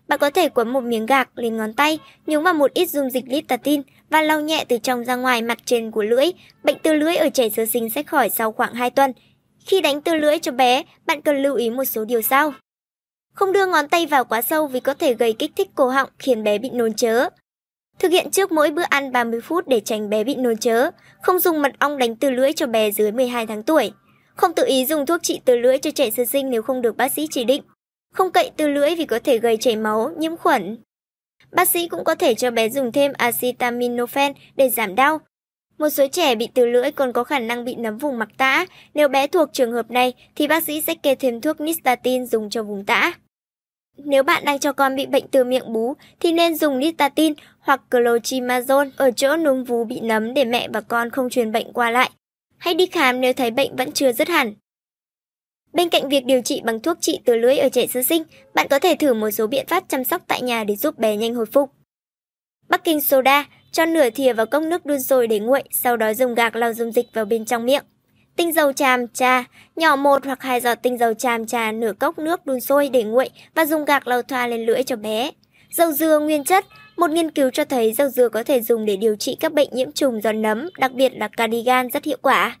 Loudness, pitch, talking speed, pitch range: -19 LUFS, 270 Hz, 245 wpm, 240-305 Hz